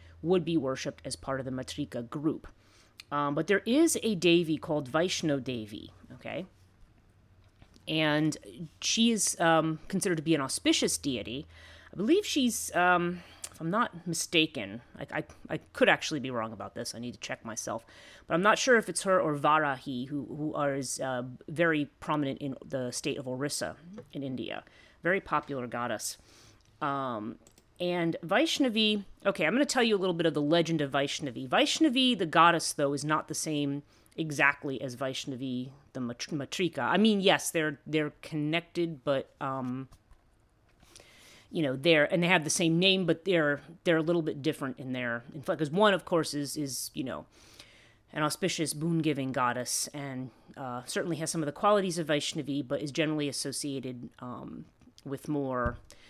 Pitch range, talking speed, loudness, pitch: 130-170 Hz, 175 wpm, -30 LUFS, 150 Hz